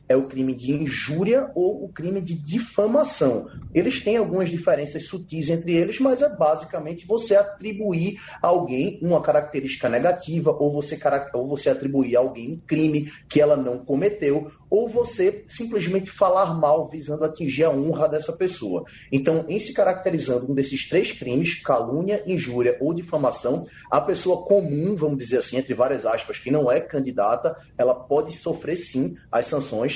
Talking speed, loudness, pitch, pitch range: 165 wpm, -23 LUFS, 155 Hz, 140-190 Hz